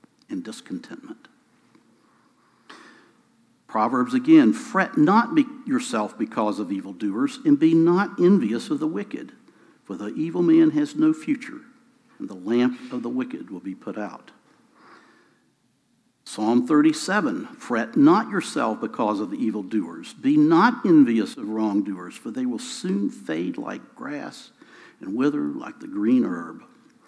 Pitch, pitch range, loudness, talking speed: 265 Hz, 190-295 Hz, -22 LUFS, 135 wpm